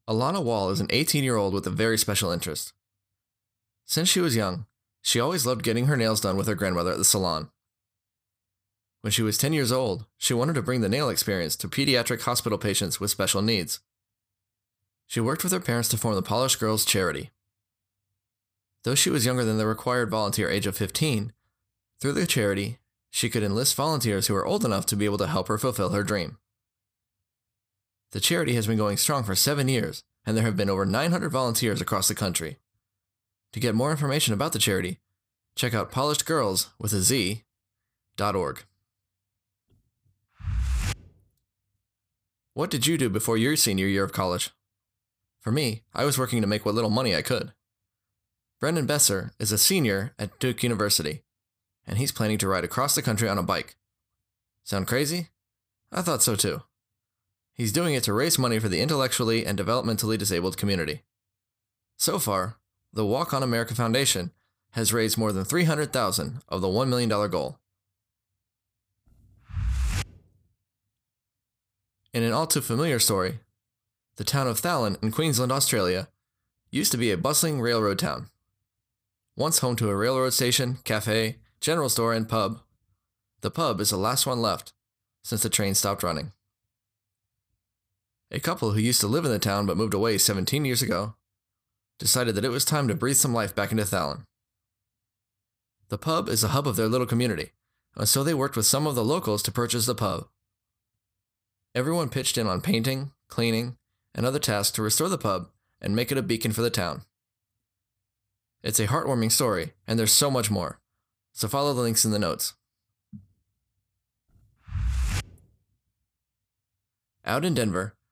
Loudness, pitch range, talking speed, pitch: -25 LUFS, 100-120 Hz, 170 wpm, 110 Hz